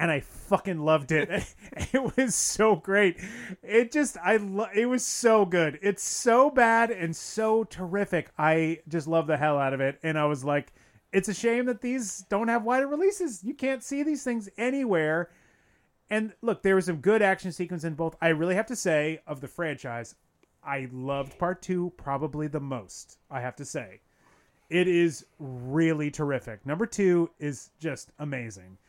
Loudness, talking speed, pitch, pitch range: -27 LUFS, 185 wpm, 175 Hz, 150-220 Hz